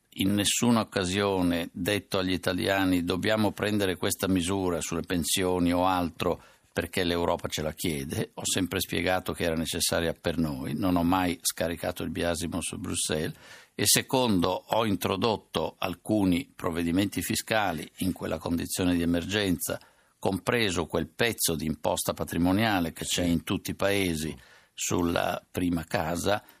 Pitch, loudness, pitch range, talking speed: 90 Hz, -28 LUFS, 85-95 Hz, 140 wpm